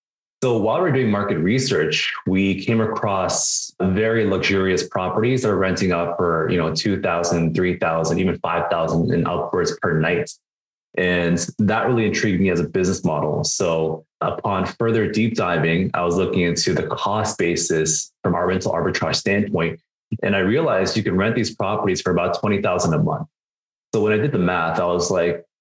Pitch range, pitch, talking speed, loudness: 85-105 Hz, 90 Hz, 185 wpm, -20 LUFS